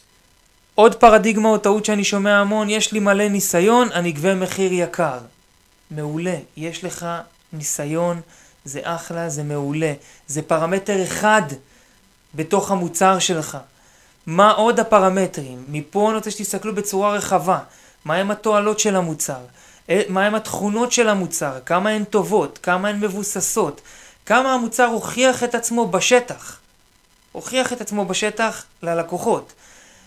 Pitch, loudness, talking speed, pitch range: 190 Hz, -19 LUFS, 130 wpm, 165-215 Hz